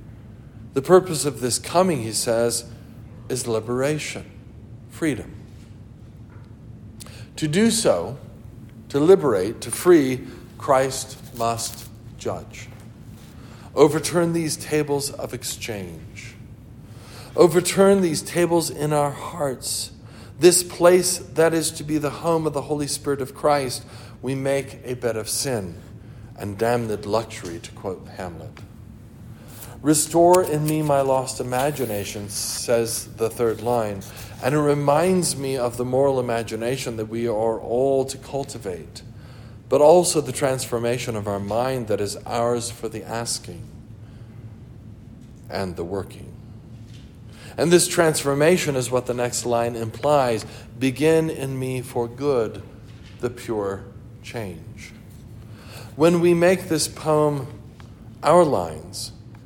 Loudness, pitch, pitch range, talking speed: -22 LUFS, 120 Hz, 115-140 Hz, 120 wpm